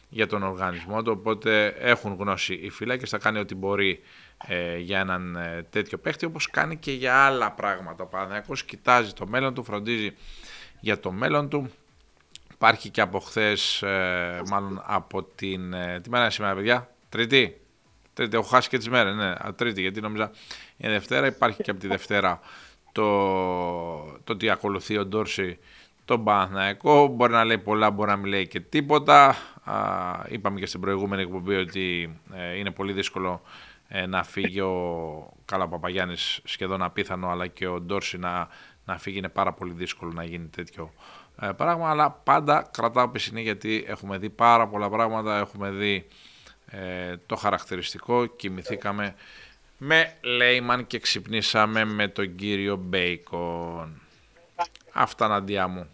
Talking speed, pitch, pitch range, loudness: 150 wpm, 100 Hz, 90-110 Hz, -25 LUFS